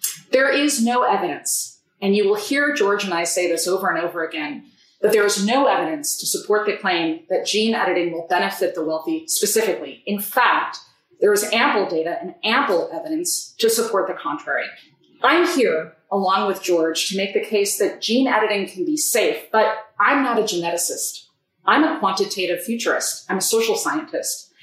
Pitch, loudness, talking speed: 210 Hz, -20 LUFS, 185 wpm